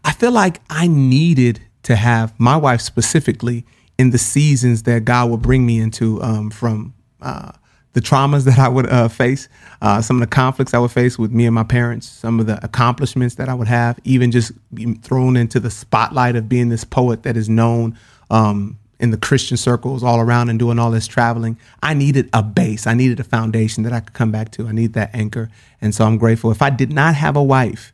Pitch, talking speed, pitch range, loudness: 120 Hz, 225 wpm, 115-130 Hz, -16 LUFS